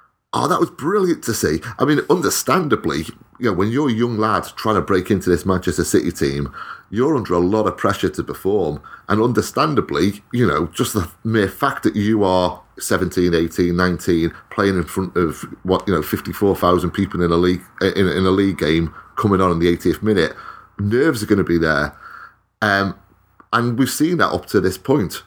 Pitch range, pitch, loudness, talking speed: 90-105 Hz, 95 Hz, -19 LUFS, 200 wpm